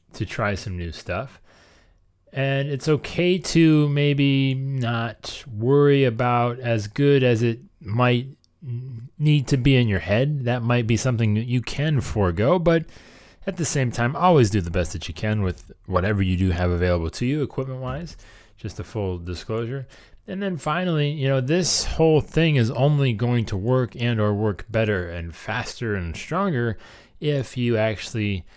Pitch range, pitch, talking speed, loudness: 105-140 Hz, 120 Hz, 170 wpm, -22 LUFS